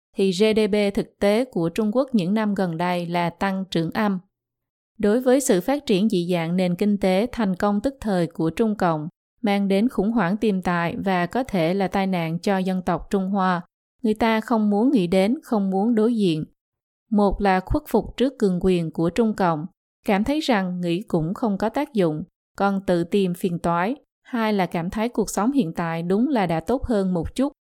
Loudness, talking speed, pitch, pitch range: -22 LUFS, 210 wpm, 200 Hz, 180-220 Hz